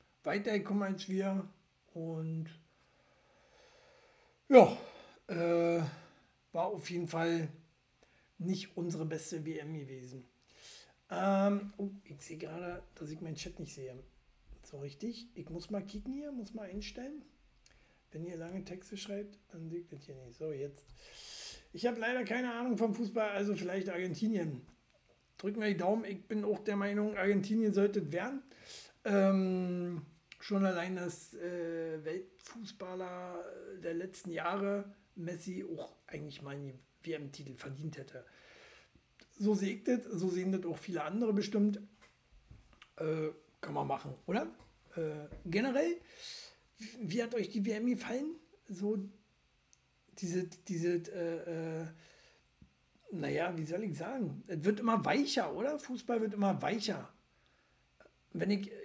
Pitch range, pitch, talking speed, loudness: 160-210 Hz, 185 Hz, 135 wpm, -36 LUFS